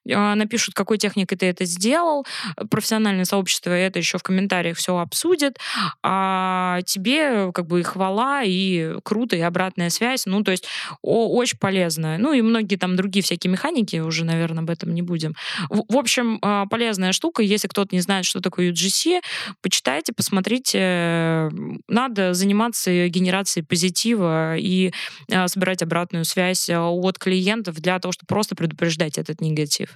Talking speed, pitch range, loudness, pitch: 150 wpm, 175-210 Hz, -21 LUFS, 190 Hz